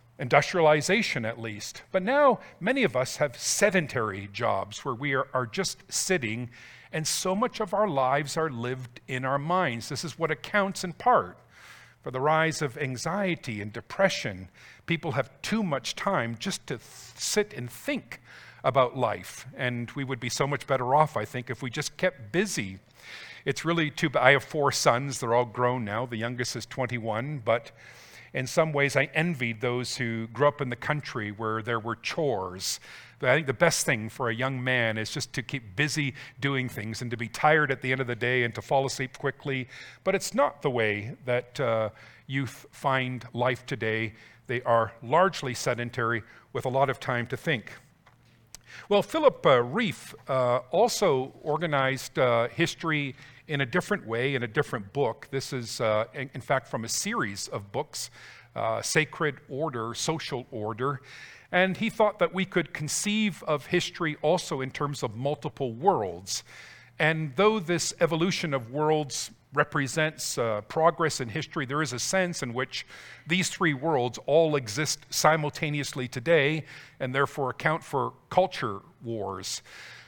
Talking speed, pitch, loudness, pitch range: 175 wpm, 135 Hz, -28 LUFS, 120-155 Hz